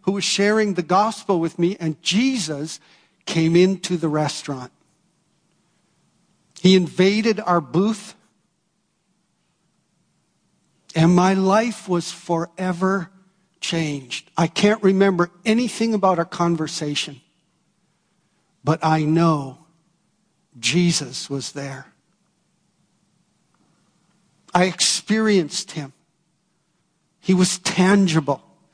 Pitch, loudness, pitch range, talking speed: 180 Hz, -20 LUFS, 165-195 Hz, 90 wpm